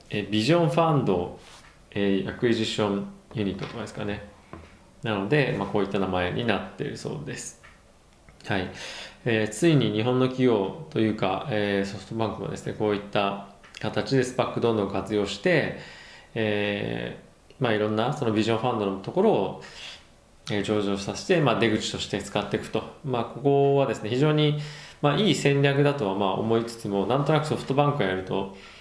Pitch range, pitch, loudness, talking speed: 100-125 Hz, 110 Hz, -26 LUFS, 375 characters per minute